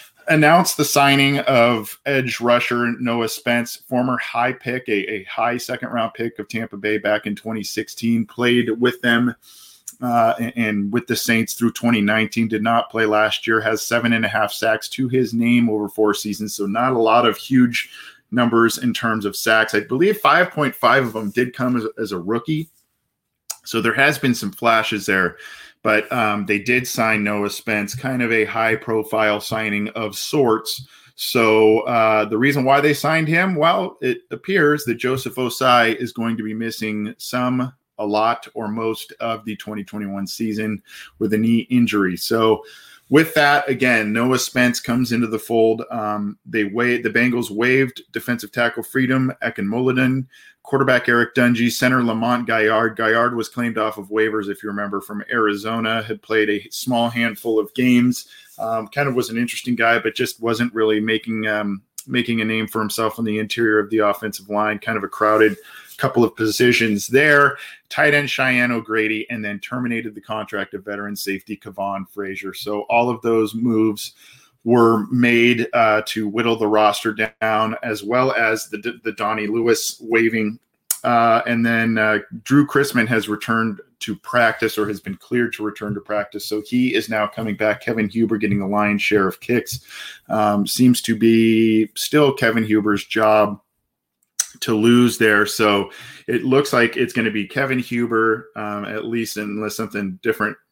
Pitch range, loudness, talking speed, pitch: 105-120 Hz, -19 LUFS, 175 wpm, 115 Hz